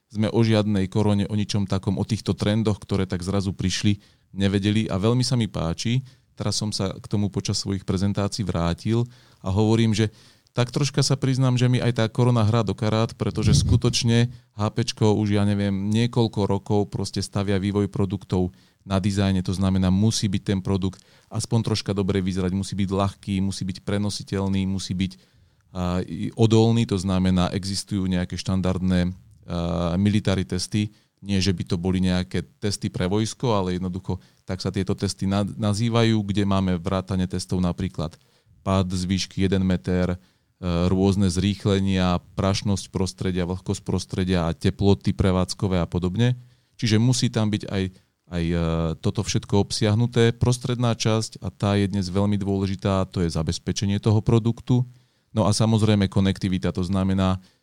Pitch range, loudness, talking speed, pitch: 95-110 Hz, -23 LUFS, 155 wpm, 100 Hz